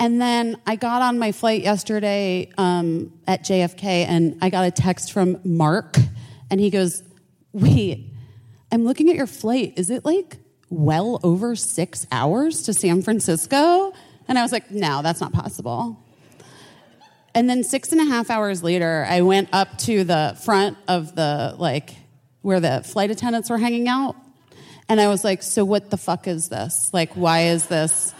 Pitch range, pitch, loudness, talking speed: 165-225 Hz, 190 Hz, -20 LUFS, 175 wpm